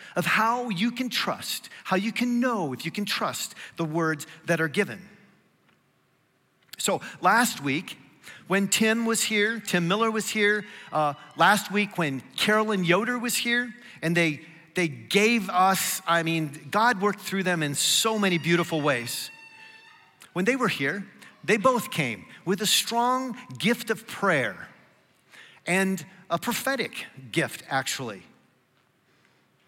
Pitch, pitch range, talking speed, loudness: 200 Hz, 170-225 Hz, 145 wpm, -25 LUFS